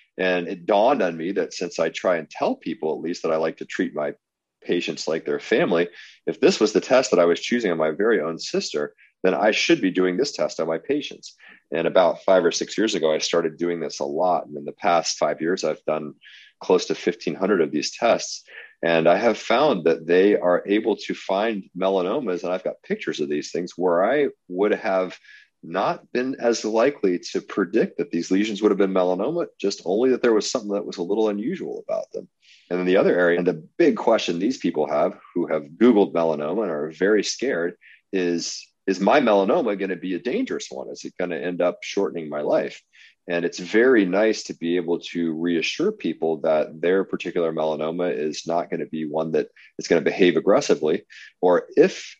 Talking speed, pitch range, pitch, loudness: 220 wpm, 85-95 Hz, 90 Hz, -22 LUFS